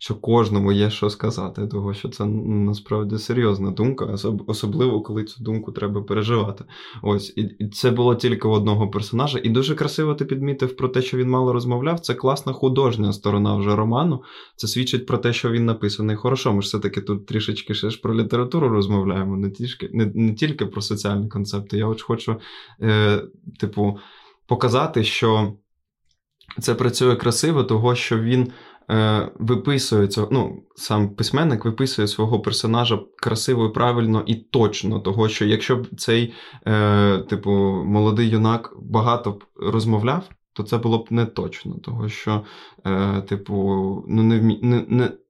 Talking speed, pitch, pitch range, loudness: 160 wpm, 110 Hz, 105-120 Hz, -21 LUFS